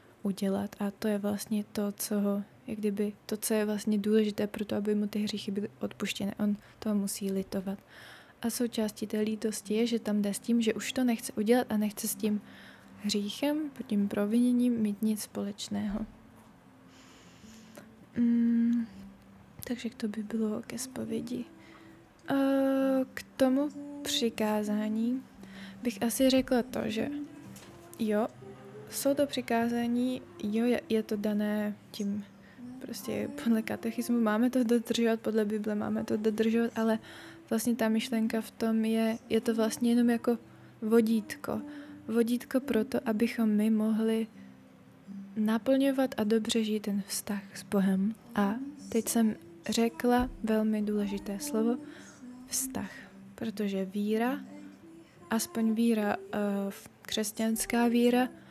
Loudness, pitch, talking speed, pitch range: -31 LUFS, 220 Hz, 130 wpm, 210-235 Hz